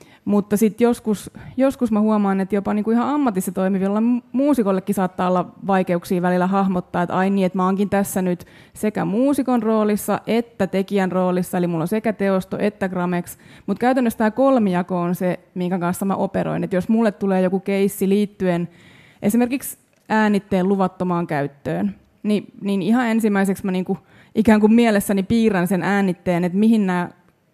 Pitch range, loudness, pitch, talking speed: 185-215 Hz, -20 LUFS, 195 Hz, 170 wpm